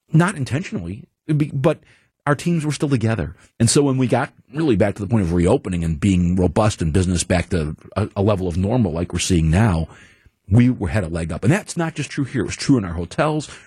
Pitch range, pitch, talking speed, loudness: 90-140 Hz, 110 Hz, 235 wpm, -20 LUFS